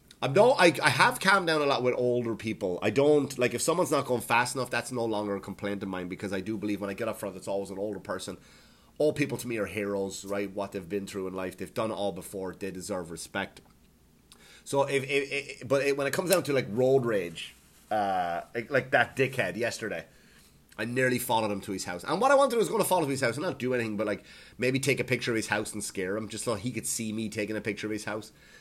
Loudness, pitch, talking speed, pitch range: -29 LUFS, 110 Hz, 275 wpm, 100-130 Hz